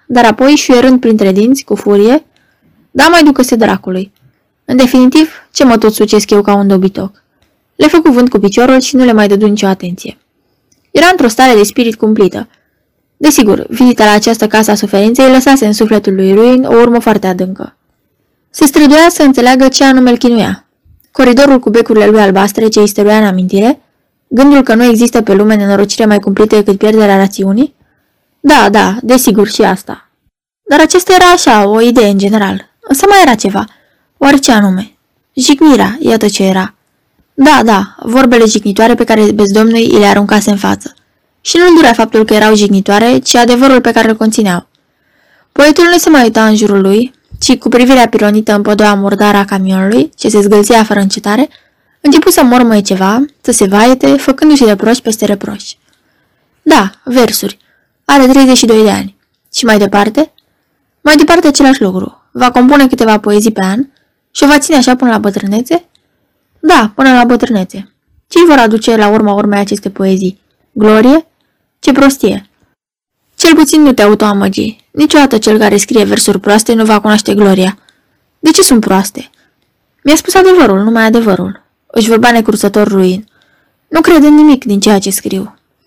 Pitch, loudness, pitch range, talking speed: 225 Hz, -7 LUFS, 205-270 Hz, 170 wpm